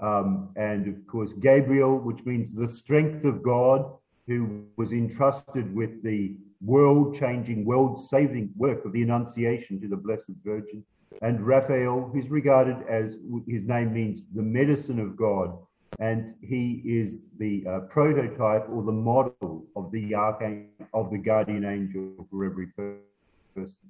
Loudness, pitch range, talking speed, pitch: -26 LUFS, 105-130 Hz, 150 wpm, 115 Hz